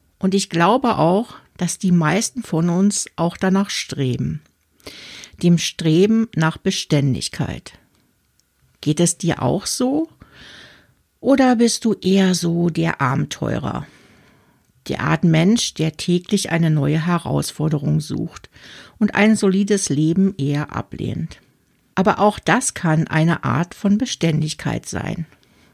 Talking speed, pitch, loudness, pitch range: 120 wpm, 170 Hz, -19 LUFS, 155-200 Hz